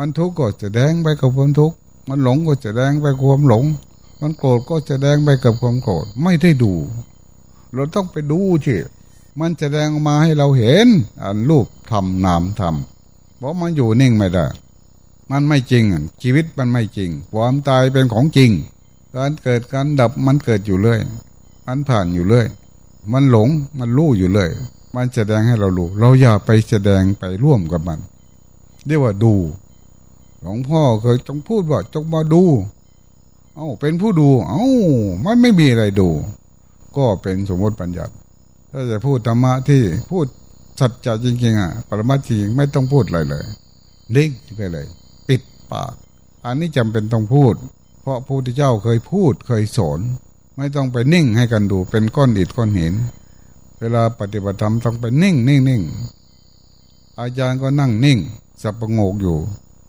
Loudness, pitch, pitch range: -16 LUFS, 125 Hz, 105-140 Hz